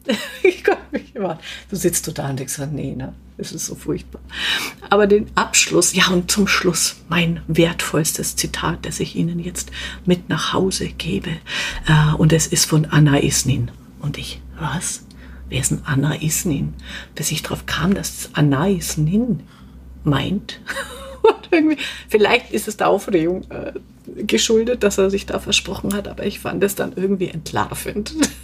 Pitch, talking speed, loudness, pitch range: 175 Hz, 165 wpm, -19 LUFS, 150-200 Hz